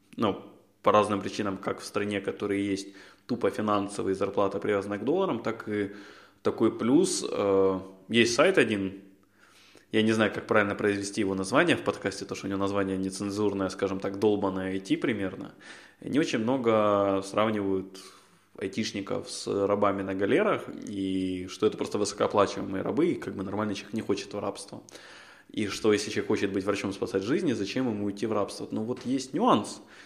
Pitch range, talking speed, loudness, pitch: 95-105 Hz, 170 wpm, -28 LUFS, 100 Hz